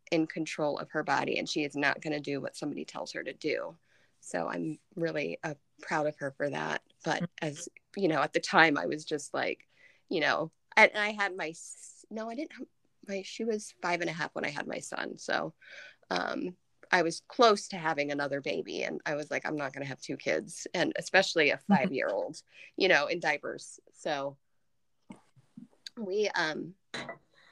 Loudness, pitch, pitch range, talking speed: -31 LUFS, 165 Hz, 145-200 Hz, 205 wpm